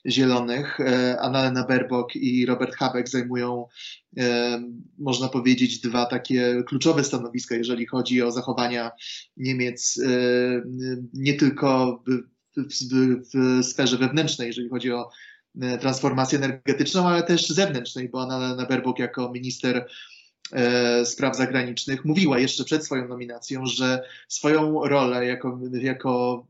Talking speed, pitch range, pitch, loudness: 115 wpm, 125-130 Hz, 125 Hz, -24 LUFS